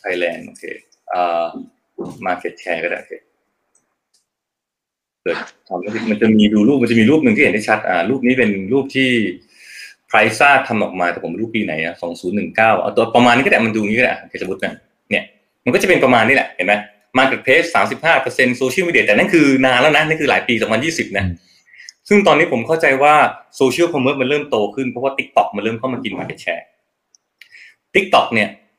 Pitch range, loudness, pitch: 105-135 Hz, -15 LUFS, 115 Hz